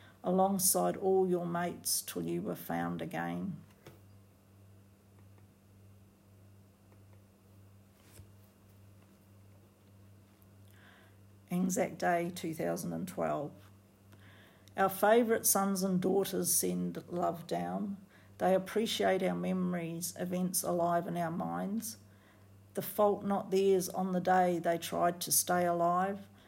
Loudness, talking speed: -32 LUFS, 100 wpm